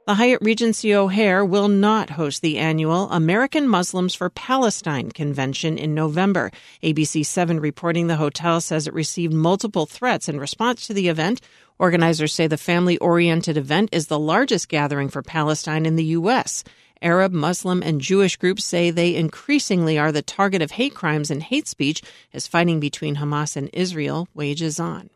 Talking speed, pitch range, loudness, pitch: 170 wpm, 155-195 Hz, -20 LUFS, 170 Hz